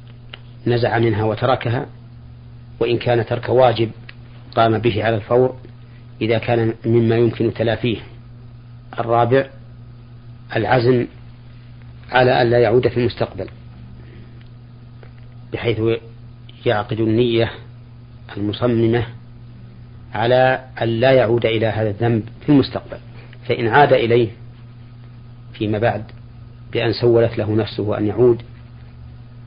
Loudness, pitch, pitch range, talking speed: -18 LUFS, 120 Hz, 115-120 Hz, 95 wpm